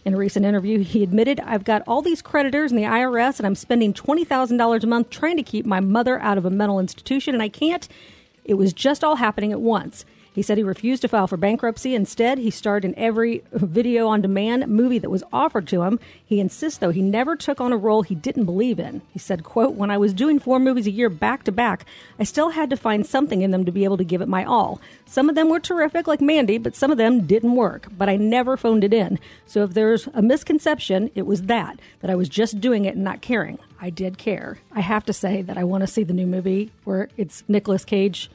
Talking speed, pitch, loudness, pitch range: 250 wpm, 220 Hz, -21 LUFS, 195-250 Hz